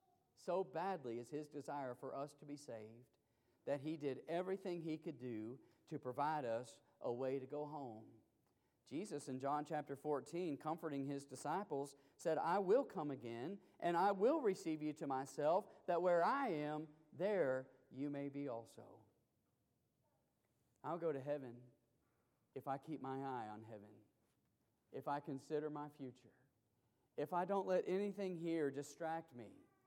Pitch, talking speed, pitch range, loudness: 145 Hz, 155 wpm, 125-155 Hz, -44 LUFS